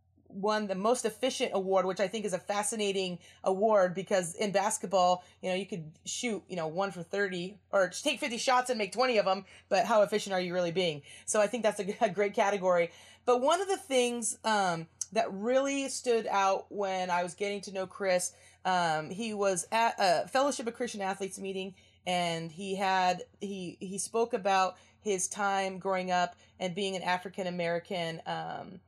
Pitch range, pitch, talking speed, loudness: 185-220 Hz, 195 Hz, 190 wpm, -31 LUFS